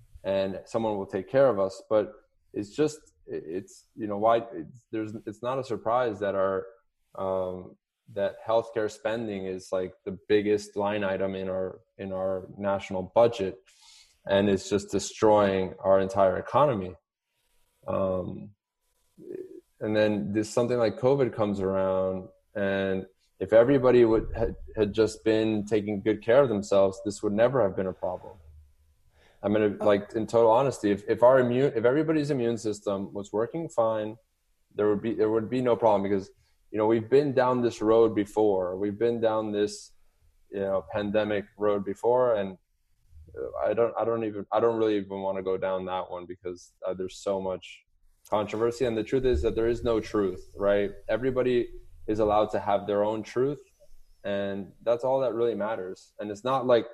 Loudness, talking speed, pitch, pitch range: -27 LUFS, 175 wpm, 105 Hz, 95-115 Hz